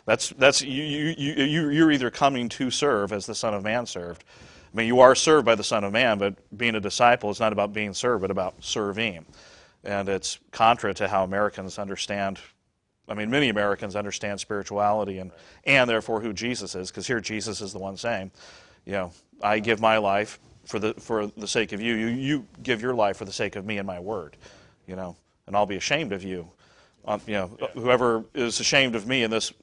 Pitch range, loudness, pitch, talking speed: 100-120 Hz, -24 LUFS, 105 Hz, 215 wpm